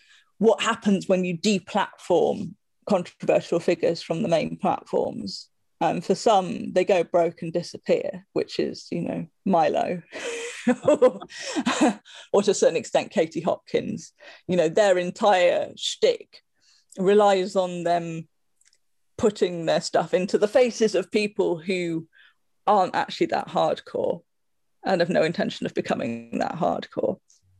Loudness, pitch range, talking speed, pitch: -24 LUFS, 175-270 Hz, 135 wpm, 200 Hz